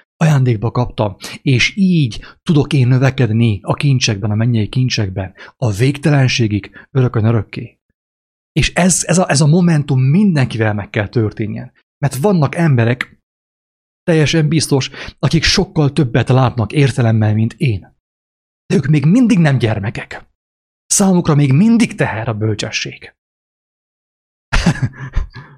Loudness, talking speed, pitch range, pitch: -14 LUFS, 120 wpm, 110-155 Hz, 130 Hz